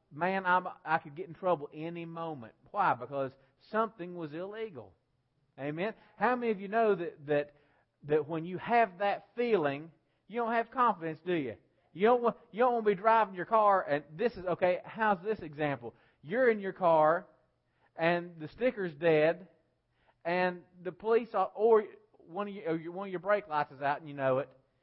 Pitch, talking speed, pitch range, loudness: 175 Hz, 195 wpm, 150-210 Hz, -31 LUFS